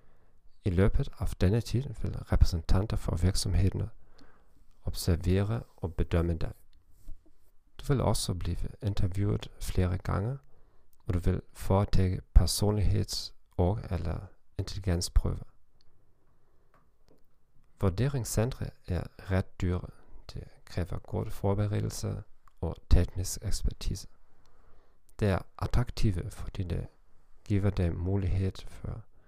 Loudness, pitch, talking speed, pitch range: -32 LUFS, 95 Hz, 75 wpm, 90-105 Hz